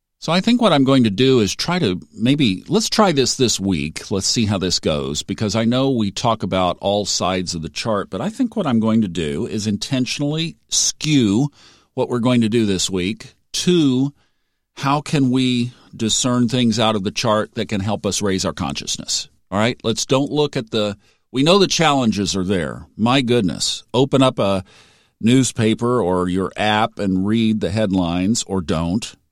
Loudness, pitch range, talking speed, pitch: -18 LUFS, 95-130 Hz, 195 wpm, 110 Hz